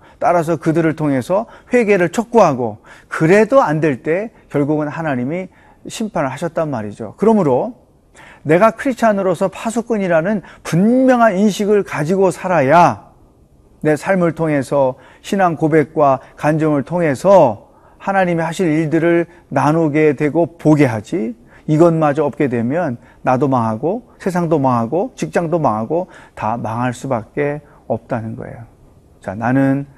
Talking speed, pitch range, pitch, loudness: 290 characters per minute, 135-190 Hz, 160 Hz, -16 LUFS